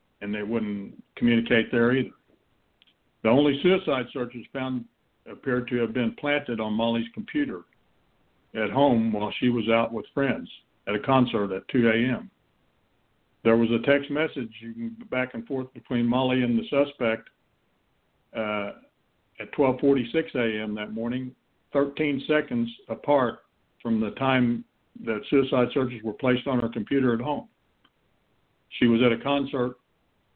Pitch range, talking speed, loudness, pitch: 115-135 Hz, 145 wpm, -26 LUFS, 120 Hz